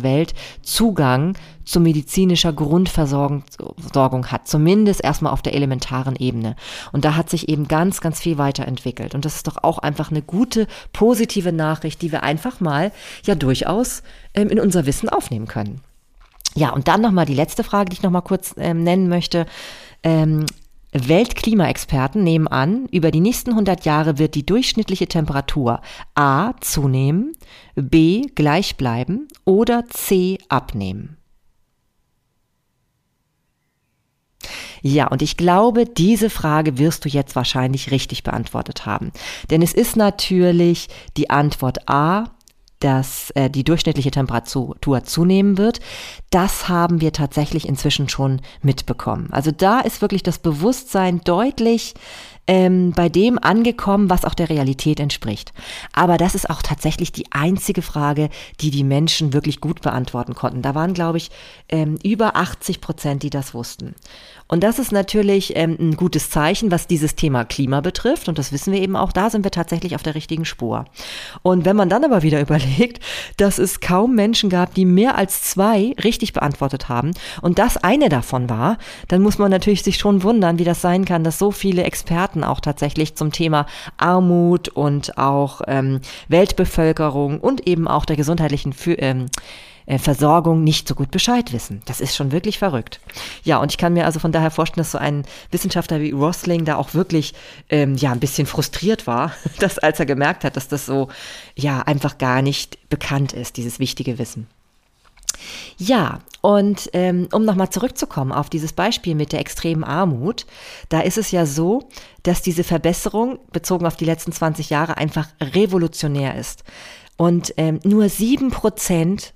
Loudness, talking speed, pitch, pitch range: -18 LUFS, 160 wpm, 160 Hz, 145-190 Hz